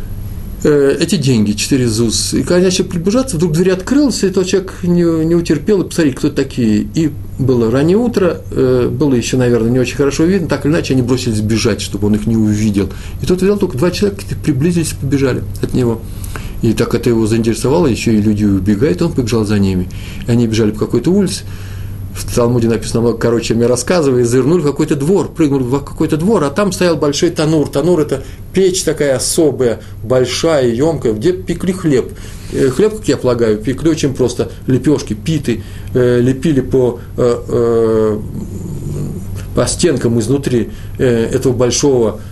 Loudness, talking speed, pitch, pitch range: -14 LUFS, 165 wpm, 125 Hz, 110-155 Hz